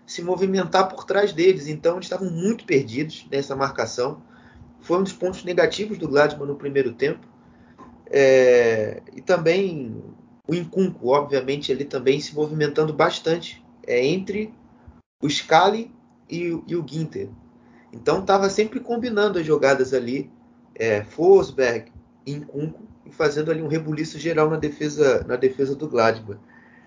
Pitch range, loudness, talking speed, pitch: 140-190 Hz, -22 LUFS, 145 wpm, 155 Hz